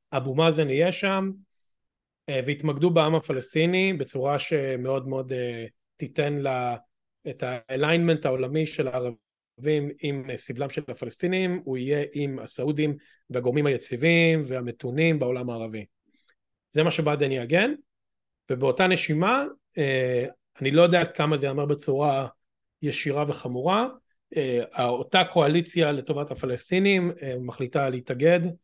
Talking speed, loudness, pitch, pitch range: 105 wpm, -25 LUFS, 145 Hz, 130-165 Hz